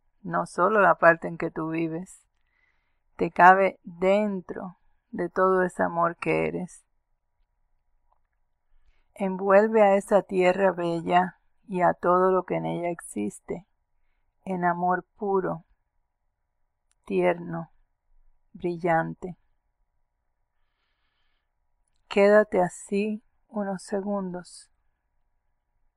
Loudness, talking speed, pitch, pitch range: -24 LUFS, 90 wpm, 180 Hz, 170-195 Hz